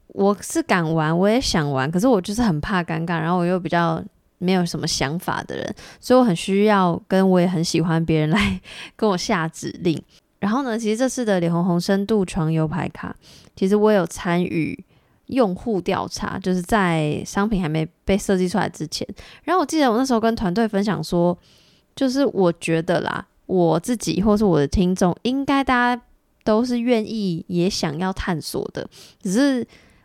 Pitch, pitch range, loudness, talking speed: 190 Hz, 170-220 Hz, -21 LUFS, 275 characters per minute